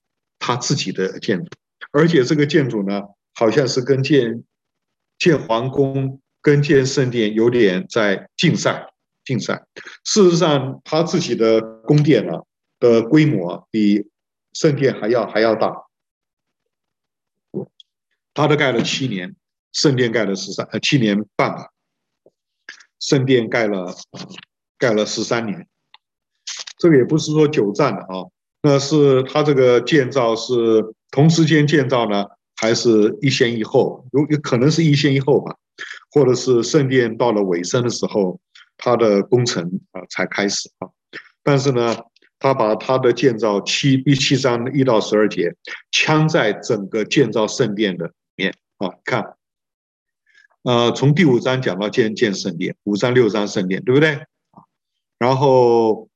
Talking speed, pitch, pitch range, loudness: 210 characters per minute, 130 Hz, 110-150 Hz, -17 LUFS